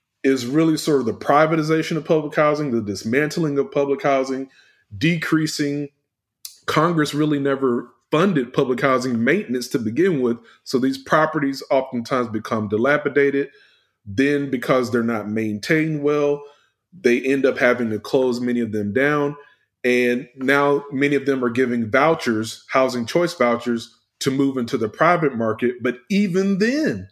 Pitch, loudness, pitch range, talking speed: 135 Hz, -20 LUFS, 120-150 Hz, 150 wpm